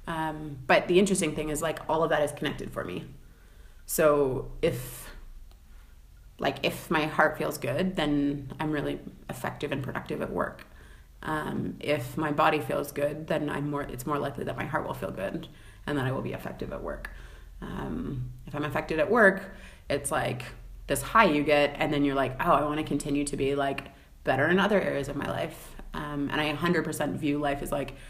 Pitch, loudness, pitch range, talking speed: 145 Hz, -28 LUFS, 130-155 Hz, 205 wpm